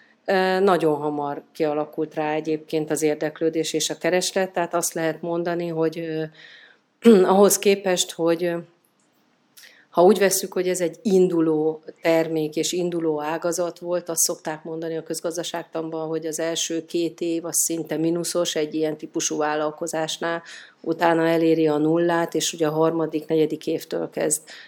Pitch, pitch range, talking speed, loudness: 165 Hz, 155-175 Hz, 140 wpm, -22 LUFS